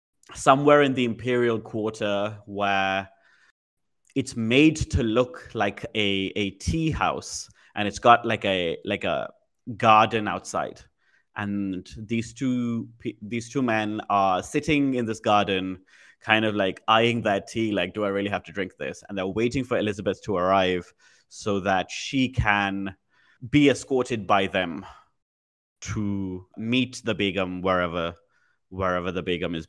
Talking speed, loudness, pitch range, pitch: 150 wpm, -24 LUFS, 95-120 Hz, 105 Hz